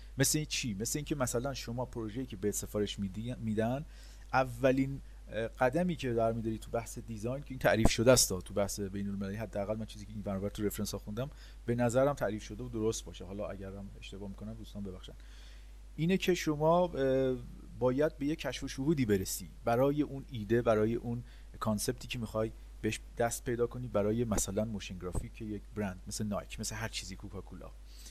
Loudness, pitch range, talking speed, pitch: -34 LUFS, 100-130 Hz, 185 wpm, 115 Hz